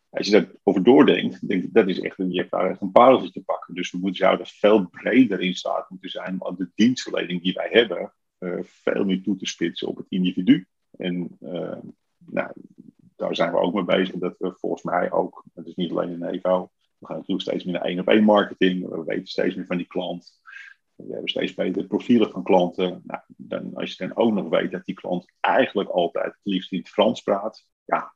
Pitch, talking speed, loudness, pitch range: 90 Hz, 225 wpm, -23 LUFS, 90-95 Hz